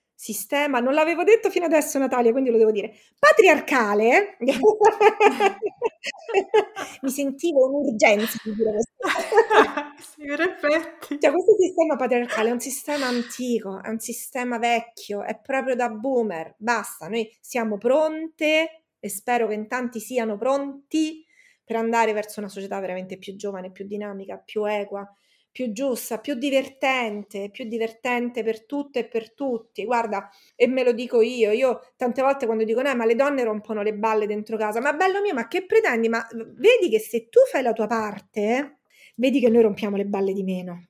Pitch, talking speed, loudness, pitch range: 245 Hz, 160 wpm, -22 LUFS, 220-295 Hz